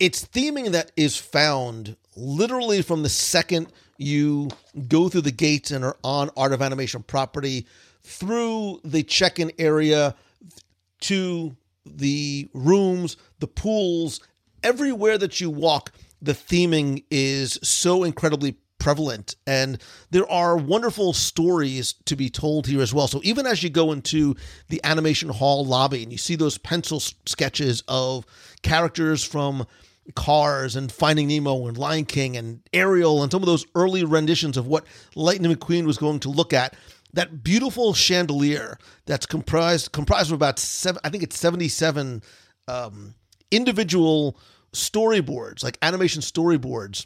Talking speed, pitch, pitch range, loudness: 145 wpm, 150 Hz, 135-170 Hz, -22 LUFS